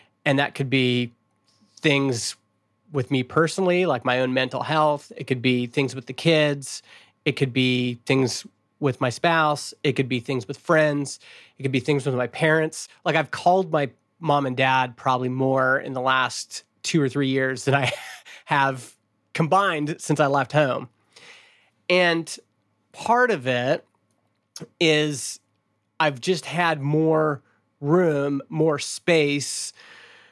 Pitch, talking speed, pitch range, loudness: 140 Hz, 150 wpm, 125-155 Hz, -23 LUFS